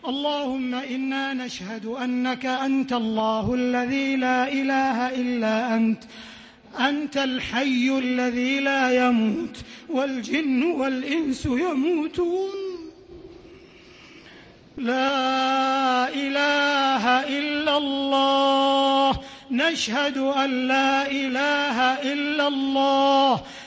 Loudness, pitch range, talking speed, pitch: -23 LUFS, 255-280 Hz, 75 wpm, 270 Hz